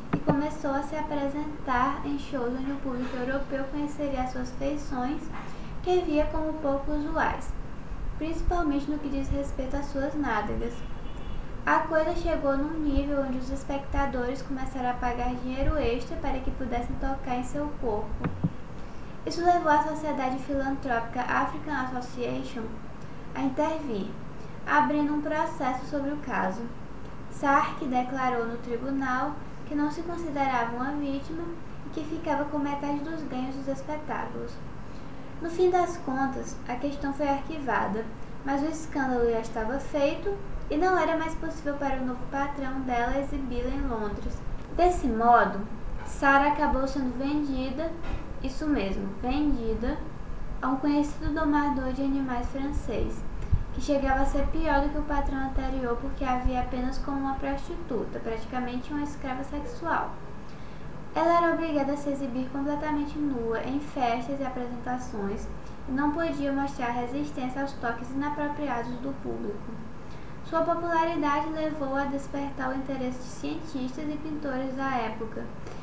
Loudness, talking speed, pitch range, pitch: -30 LUFS, 140 wpm, 255-295 Hz, 275 Hz